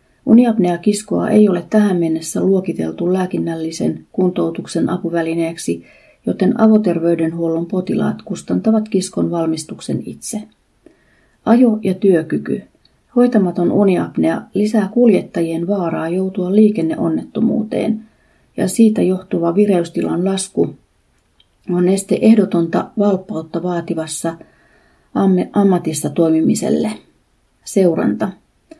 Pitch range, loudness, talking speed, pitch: 165-210 Hz, -16 LUFS, 85 wpm, 185 Hz